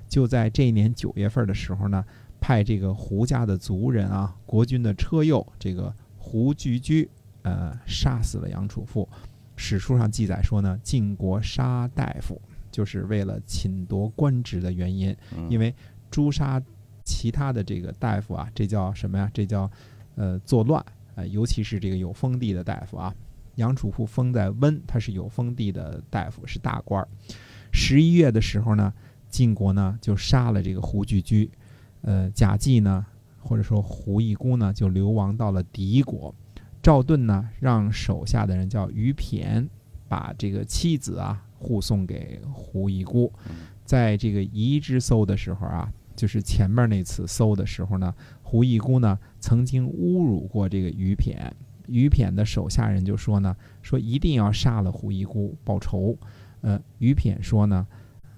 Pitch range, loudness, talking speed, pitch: 100-120 Hz, -24 LUFS, 240 characters per minute, 105 Hz